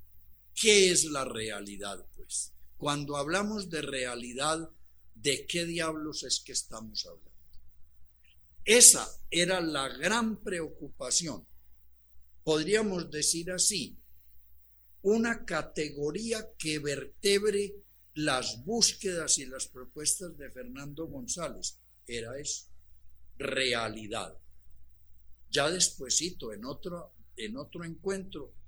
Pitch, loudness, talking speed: 145 Hz, -29 LUFS, 95 wpm